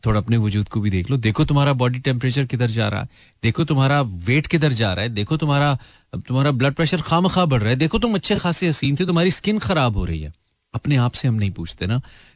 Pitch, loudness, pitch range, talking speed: 130 Hz, -20 LUFS, 110-155 Hz, 250 wpm